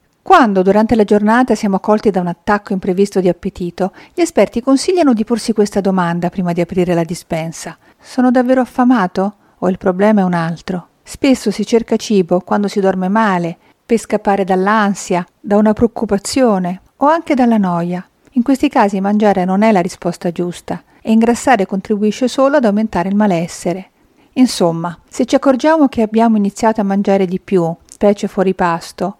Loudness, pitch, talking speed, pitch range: -14 LUFS, 205 Hz, 170 wpm, 185-235 Hz